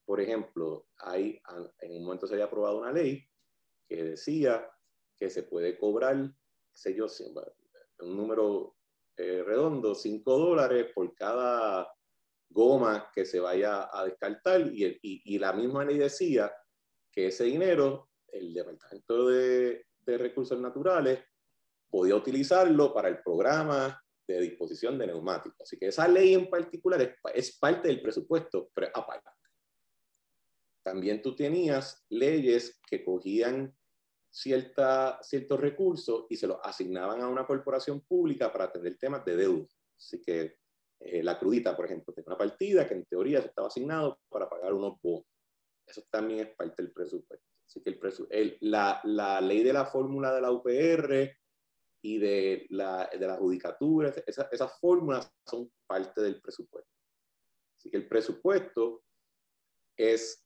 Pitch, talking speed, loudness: 135 Hz, 150 wpm, -30 LUFS